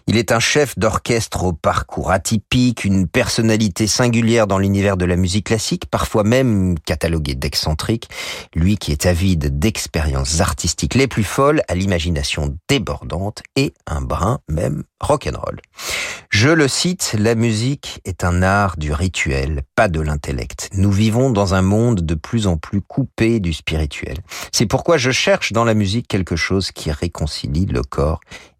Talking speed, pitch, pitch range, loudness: 160 wpm, 95 Hz, 85-115 Hz, -18 LUFS